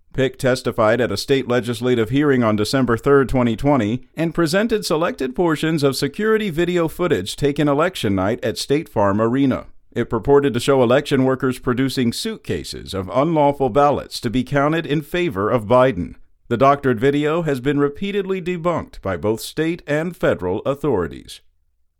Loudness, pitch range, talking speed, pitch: -19 LUFS, 120-155 Hz, 155 wpm, 140 Hz